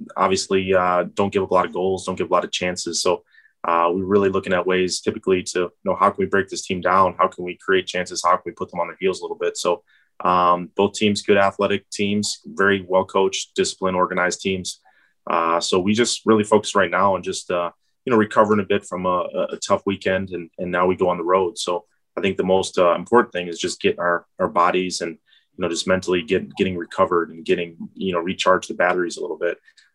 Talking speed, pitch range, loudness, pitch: 250 wpm, 90-100 Hz, -21 LUFS, 95 Hz